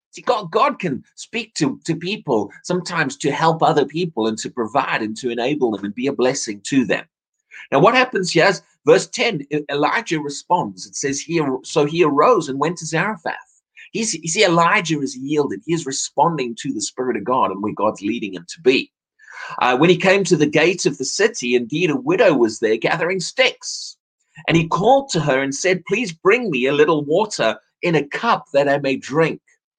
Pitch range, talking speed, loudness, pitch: 135-185 Hz, 205 wpm, -19 LUFS, 155 Hz